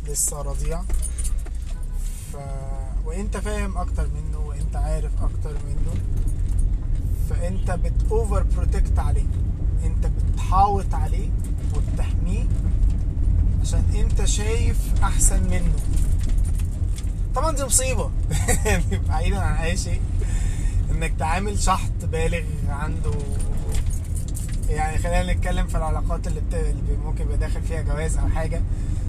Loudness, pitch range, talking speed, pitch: -25 LUFS, 85-95 Hz, 105 wpm, 90 Hz